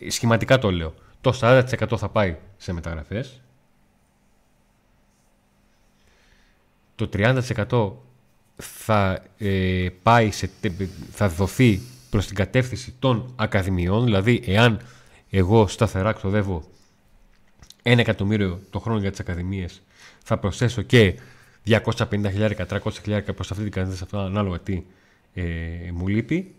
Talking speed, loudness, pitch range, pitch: 110 wpm, -23 LUFS, 95-115 Hz, 105 Hz